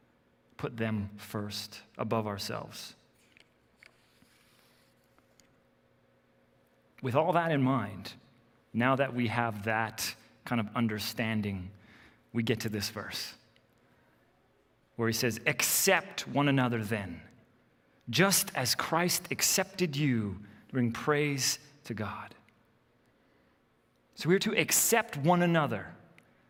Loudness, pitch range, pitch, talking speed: -30 LUFS, 100-140 Hz, 115 Hz, 100 wpm